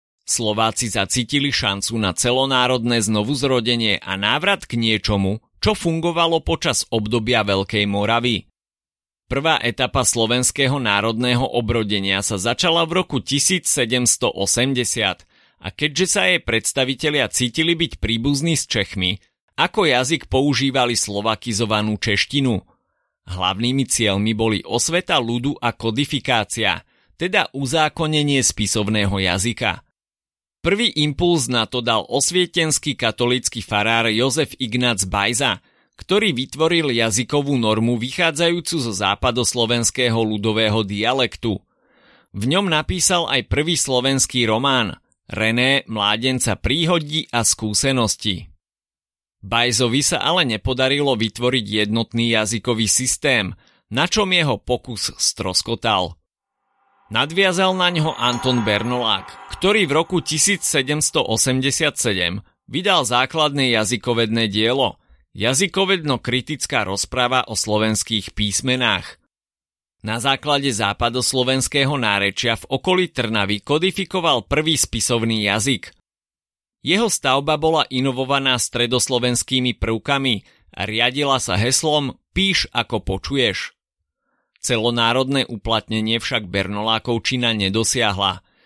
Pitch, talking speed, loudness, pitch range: 120 Hz, 95 wpm, -19 LUFS, 110-140 Hz